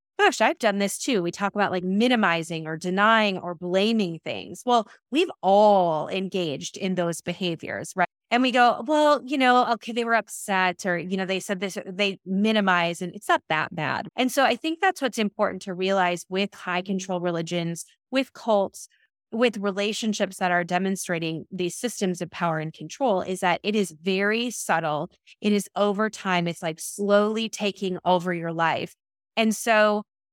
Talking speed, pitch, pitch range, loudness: 180 wpm, 195 Hz, 180-220 Hz, -24 LUFS